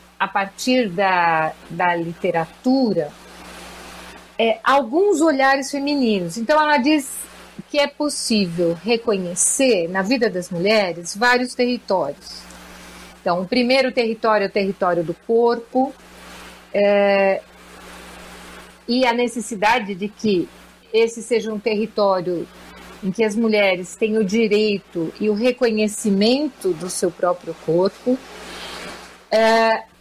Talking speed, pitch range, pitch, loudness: 110 wpm, 180-245 Hz, 215 Hz, -19 LUFS